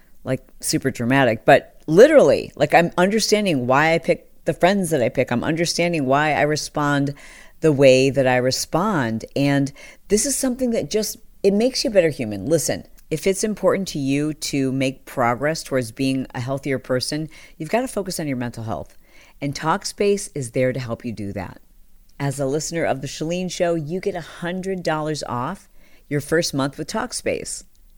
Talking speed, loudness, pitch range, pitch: 180 wpm, -20 LUFS, 130-175 Hz, 150 Hz